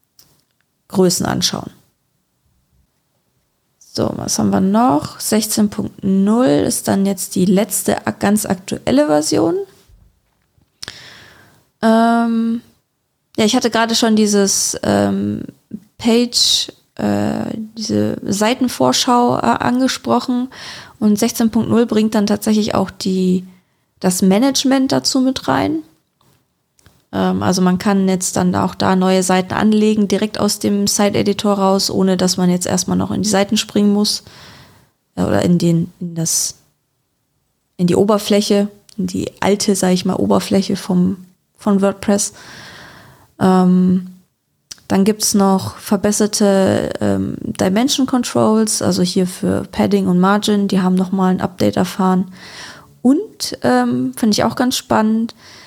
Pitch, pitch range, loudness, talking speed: 200 Hz, 185-220 Hz, -16 LUFS, 125 wpm